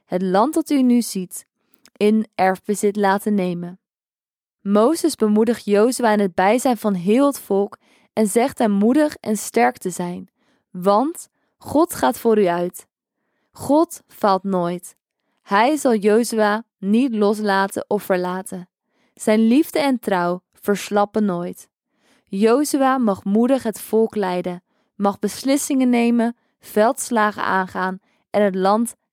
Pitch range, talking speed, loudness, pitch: 195-240 Hz, 130 wpm, -19 LUFS, 215 Hz